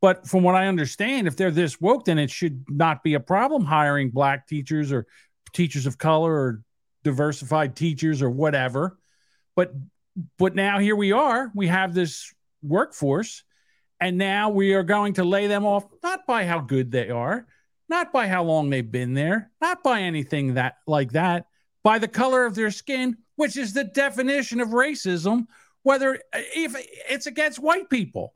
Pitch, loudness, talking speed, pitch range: 185 Hz, -23 LUFS, 180 wpm, 155-240 Hz